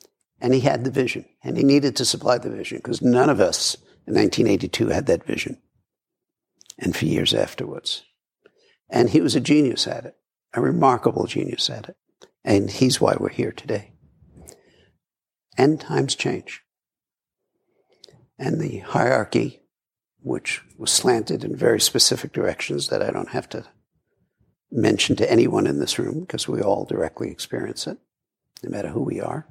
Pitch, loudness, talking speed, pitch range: 130 Hz, -22 LUFS, 160 wpm, 120-140 Hz